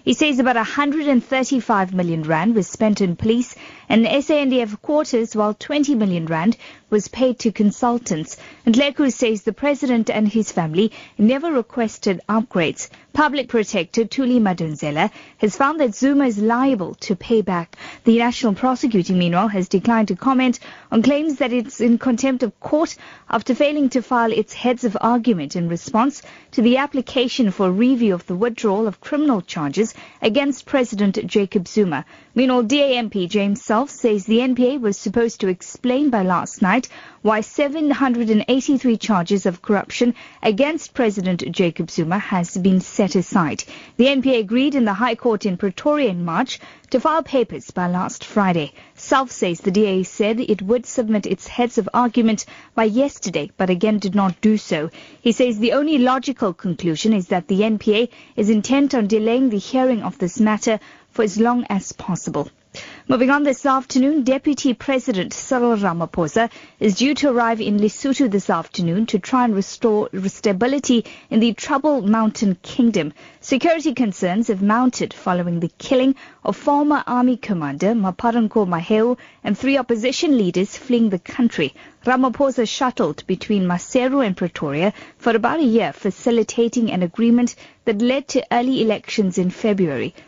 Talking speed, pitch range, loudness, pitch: 160 wpm, 200-255 Hz, -19 LUFS, 230 Hz